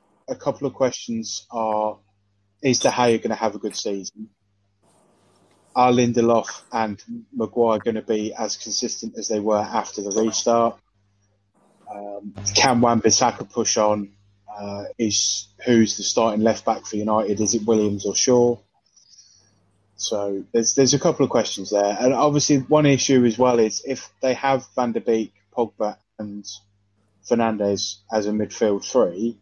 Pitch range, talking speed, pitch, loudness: 100-120 Hz, 155 wpm, 110 Hz, -21 LUFS